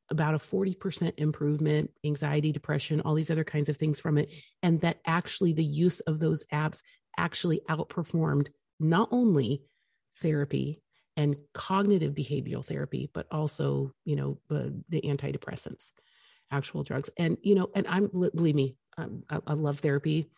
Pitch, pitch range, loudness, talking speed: 155 Hz, 145-170 Hz, -30 LUFS, 155 wpm